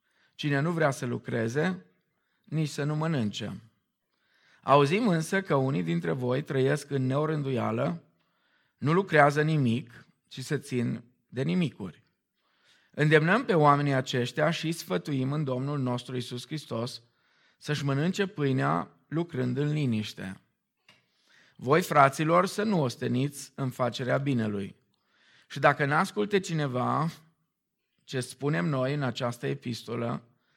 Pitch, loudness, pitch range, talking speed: 140 Hz, -28 LUFS, 125-155 Hz, 120 wpm